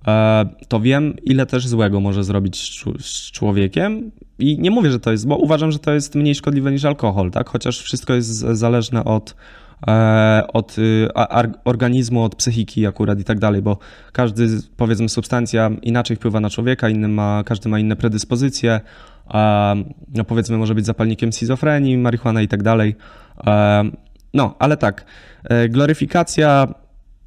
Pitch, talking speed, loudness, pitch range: 115 Hz, 145 wpm, -17 LUFS, 110-130 Hz